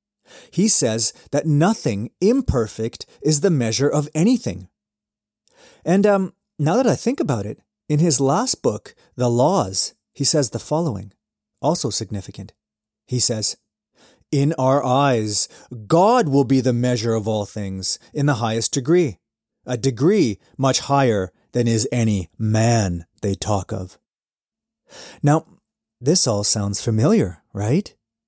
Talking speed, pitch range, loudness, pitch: 135 wpm, 105-155 Hz, -19 LUFS, 125 Hz